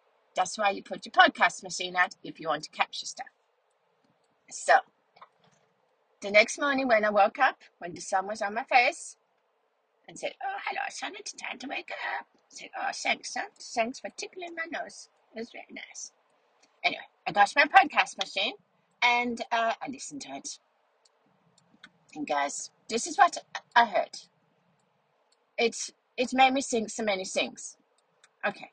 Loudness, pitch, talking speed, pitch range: -28 LUFS, 235 Hz, 170 wpm, 200-305 Hz